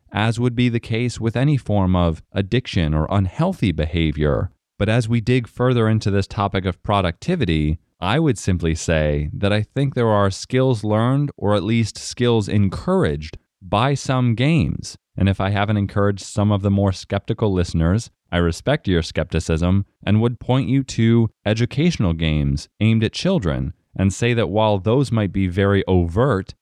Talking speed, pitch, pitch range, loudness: 170 wpm, 105 Hz, 95-120 Hz, -20 LUFS